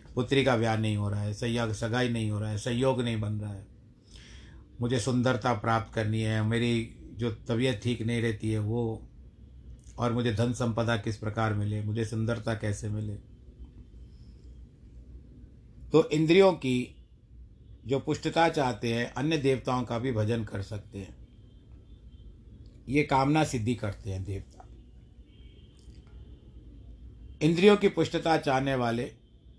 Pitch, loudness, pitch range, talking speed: 115 Hz, -28 LUFS, 105-125 Hz, 140 wpm